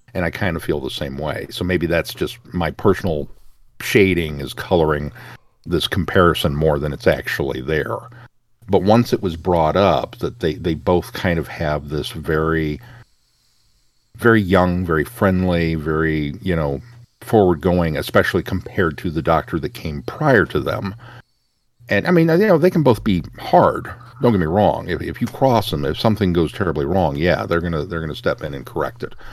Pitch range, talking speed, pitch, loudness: 80-115 Hz, 190 wpm, 90 Hz, -19 LUFS